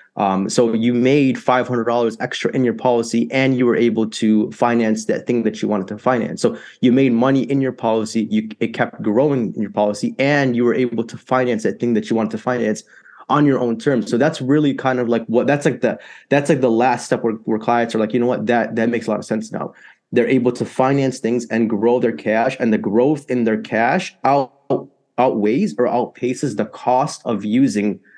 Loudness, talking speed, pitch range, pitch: -18 LUFS, 230 wpm, 115-130 Hz, 120 Hz